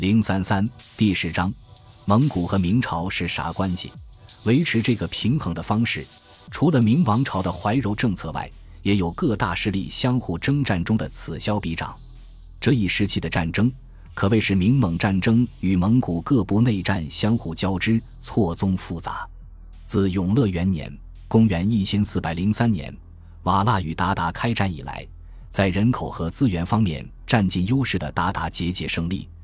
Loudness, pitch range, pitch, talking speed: -22 LUFS, 85-110 Hz, 95 Hz, 250 characters per minute